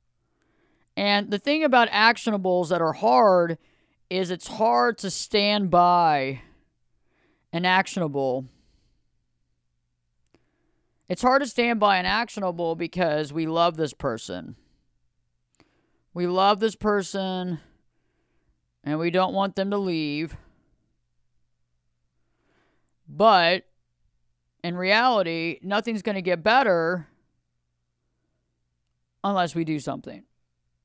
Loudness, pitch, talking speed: -23 LUFS, 165 Hz, 100 wpm